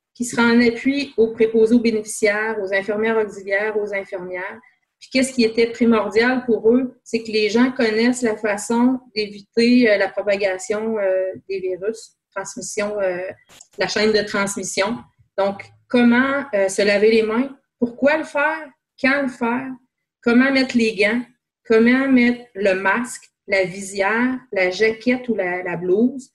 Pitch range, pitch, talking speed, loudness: 200-245 Hz, 220 Hz, 150 wpm, -19 LUFS